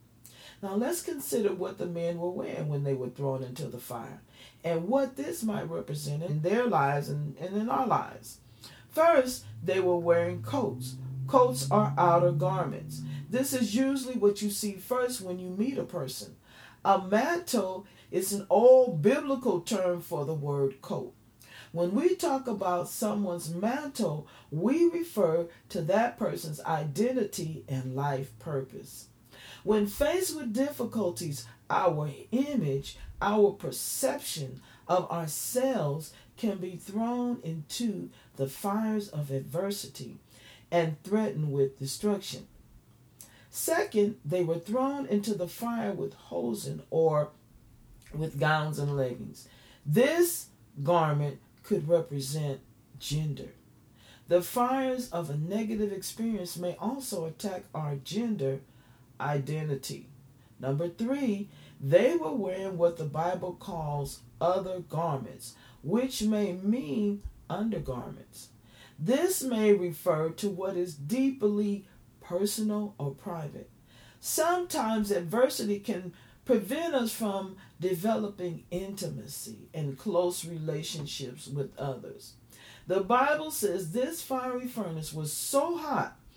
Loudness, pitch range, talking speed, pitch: -30 LUFS, 140-215 Hz, 120 wpm, 175 Hz